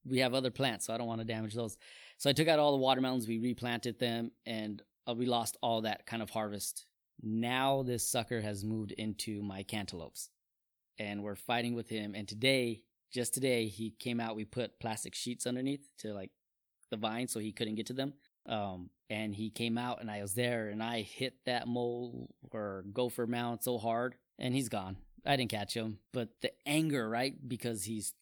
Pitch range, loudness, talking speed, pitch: 110-125 Hz, -36 LUFS, 205 wpm, 115 Hz